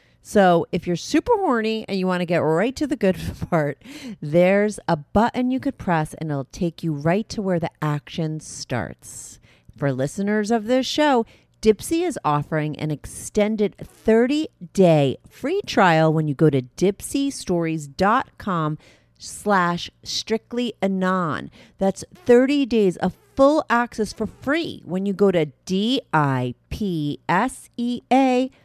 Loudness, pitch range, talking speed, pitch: -22 LUFS, 155-235 Hz, 145 wpm, 190 Hz